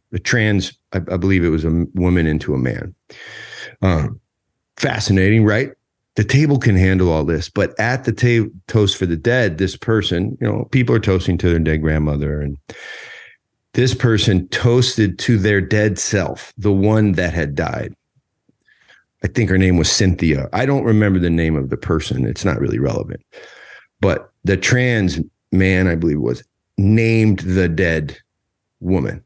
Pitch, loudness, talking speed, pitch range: 95 Hz, -17 LUFS, 170 wpm, 90-110 Hz